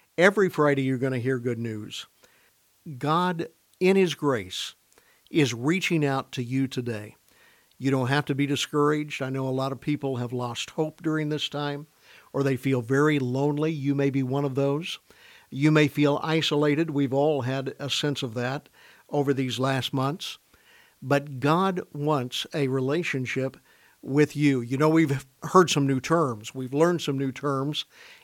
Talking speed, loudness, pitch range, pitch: 170 wpm, -26 LUFS, 135-155 Hz, 140 Hz